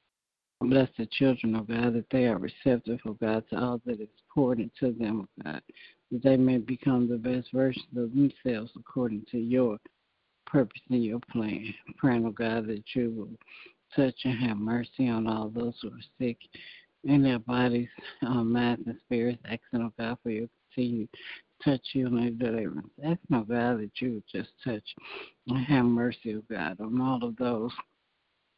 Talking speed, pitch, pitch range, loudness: 195 wpm, 120 Hz, 115-125 Hz, -30 LUFS